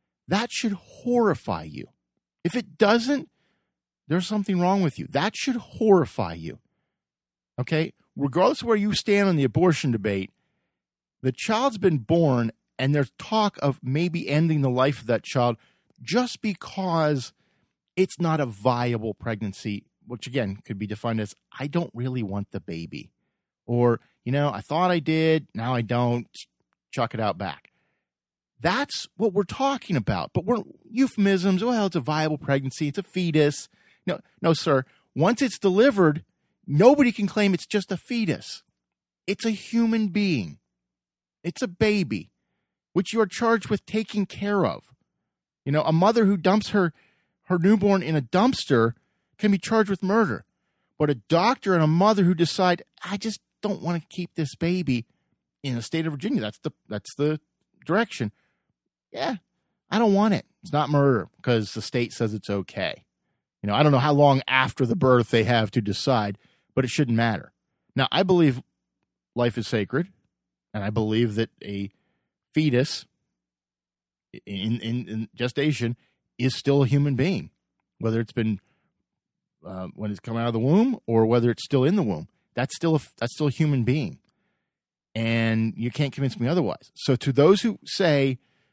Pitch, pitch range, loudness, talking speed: 150 Hz, 120-195 Hz, -24 LUFS, 170 wpm